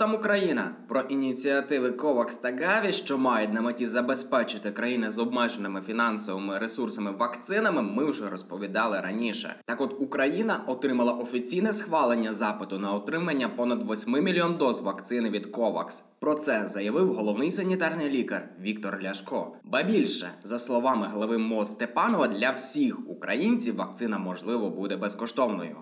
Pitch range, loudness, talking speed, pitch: 105-140 Hz, -28 LUFS, 140 wpm, 120 Hz